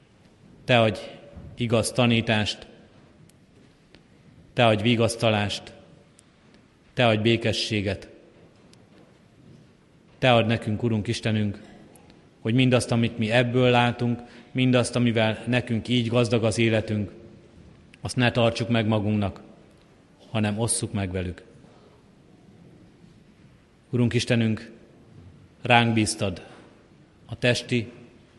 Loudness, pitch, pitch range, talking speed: -24 LUFS, 115 Hz, 110-120 Hz, 90 wpm